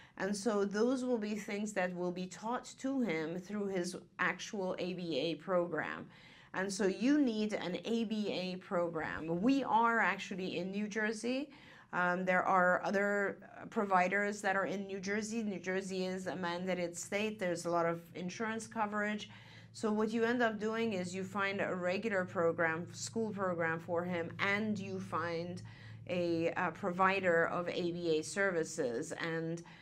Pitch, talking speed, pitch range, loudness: 185 Hz, 155 wpm, 175-210 Hz, -36 LUFS